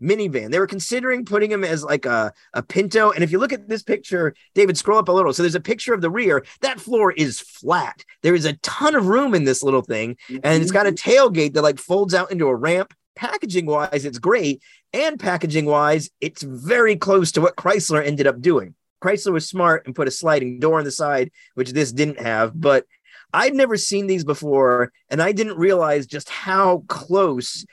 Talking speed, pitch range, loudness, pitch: 215 wpm, 150-200 Hz, -19 LUFS, 180 Hz